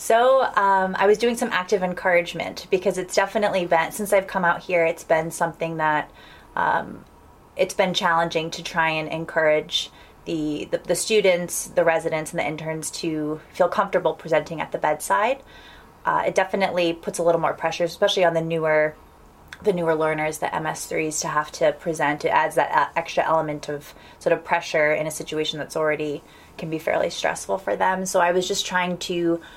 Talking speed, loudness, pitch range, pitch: 185 wpm, -22 LUFS, 155-185 Hz, 170 Hz